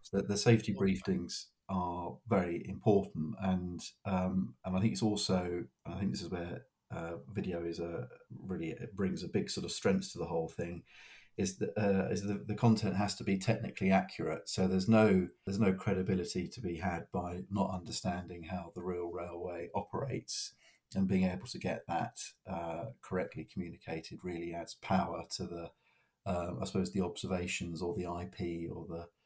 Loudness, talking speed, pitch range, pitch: -35 LUFS, 185 wpm, 85-100 Hz, 95 Hz